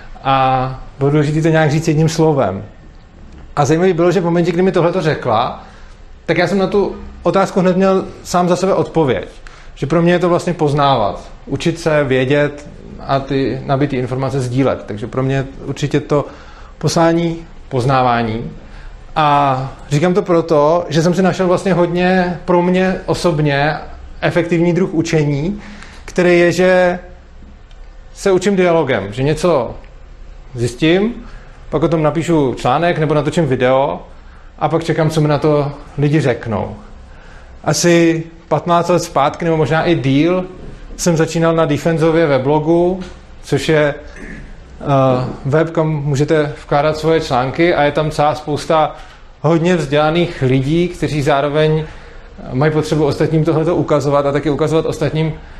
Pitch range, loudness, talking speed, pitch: 140-170 Hz, -15 LUFS, 150 wpm, 155 Hz